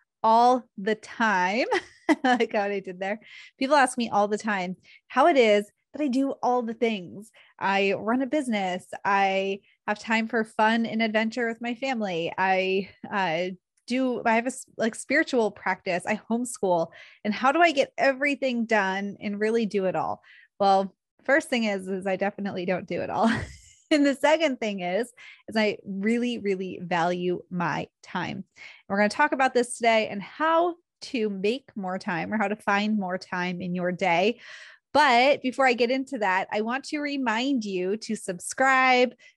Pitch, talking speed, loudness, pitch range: 215 Hz, 180 wpm, -25 LUFS, 195-255 Hz